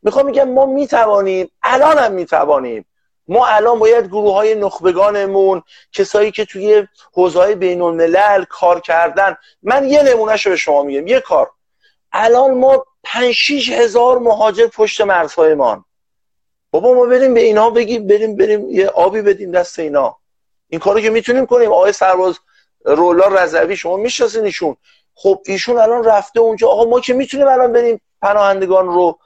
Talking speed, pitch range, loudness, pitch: 155 wpm, 195-265 Hz, -13 LUFS, 220 Hz